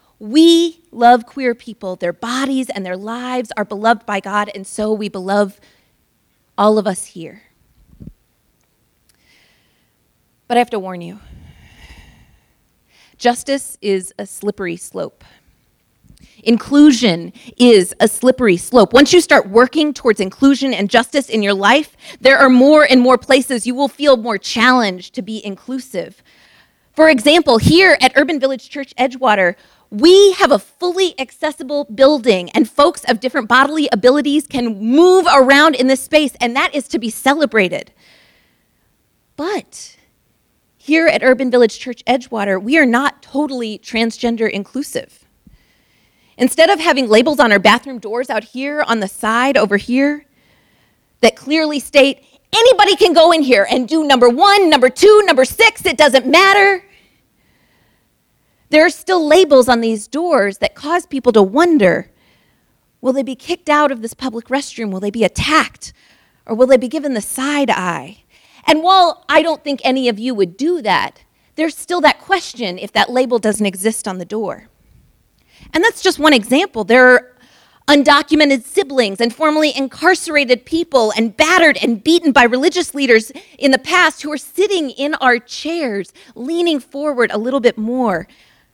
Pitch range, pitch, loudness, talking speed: 230-305 Hz, 265 Hz, -13 LUFS, 155 wpm